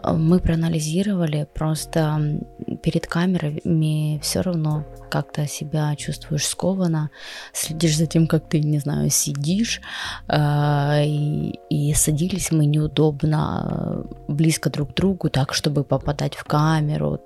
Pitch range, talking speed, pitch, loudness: 150-165 Hz, 115 wpm, 155 Hz, -22 LUFS